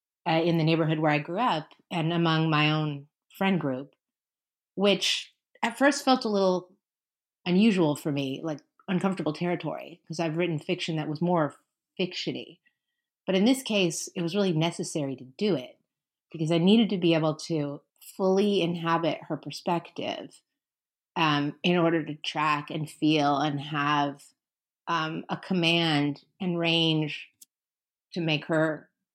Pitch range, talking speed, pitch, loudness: 150-185 Hz, 150 wpm, 165 Hz, -27 LUFS